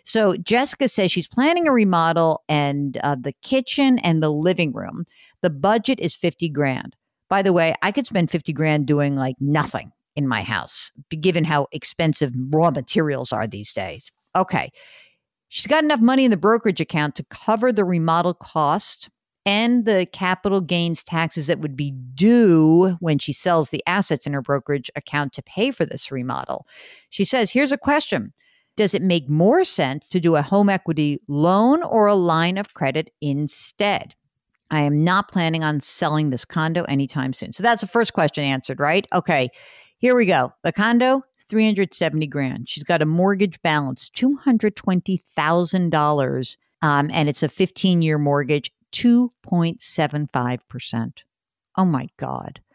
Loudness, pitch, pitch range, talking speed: -20 LUFS, 170 Hz, 145-205 Hz, 175 wpm